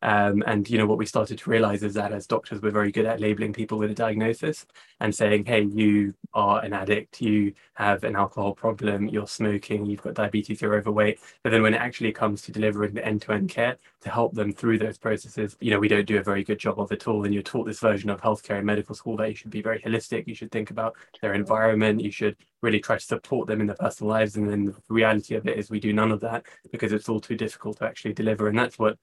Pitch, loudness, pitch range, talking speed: 105 Hz, -25 LUFS, 105-110 Hz, 260 wpm